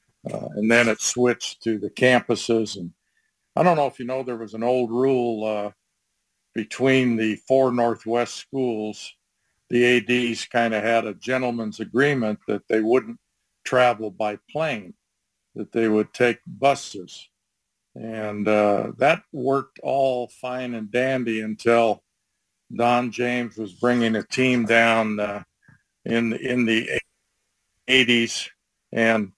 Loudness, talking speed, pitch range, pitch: -22 LUFS, 135 wpm, 110-125 Hz, 115 Hz